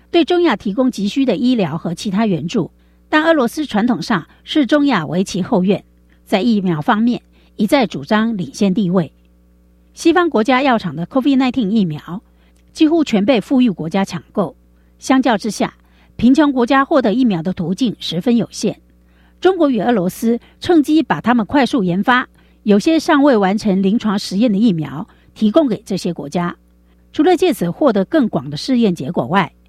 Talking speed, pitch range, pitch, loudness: 270 characters per minute, 175-260 Hz, 215 Hz, -16 LUFS